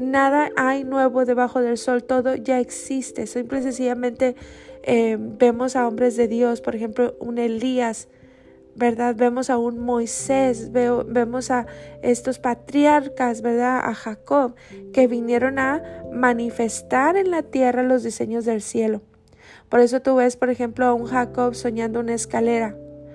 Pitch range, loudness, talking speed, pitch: 235-255 Hz, -21 LUFS, 150 wpm, 245 Hz